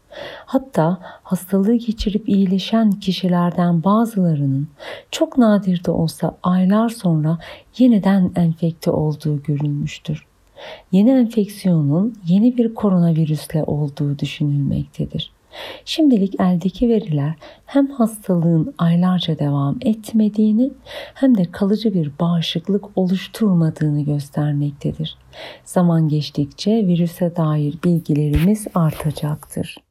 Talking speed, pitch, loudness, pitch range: 90 wpm, 180 Hz, -18 LUFS, 155-215 Hz